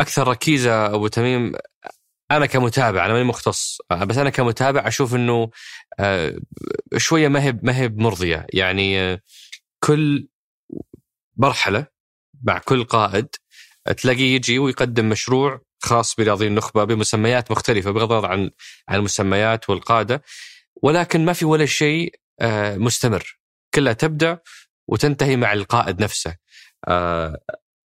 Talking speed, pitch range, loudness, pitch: 110 wpm, 105-135 Hz, -19 LUFS, 120 Hz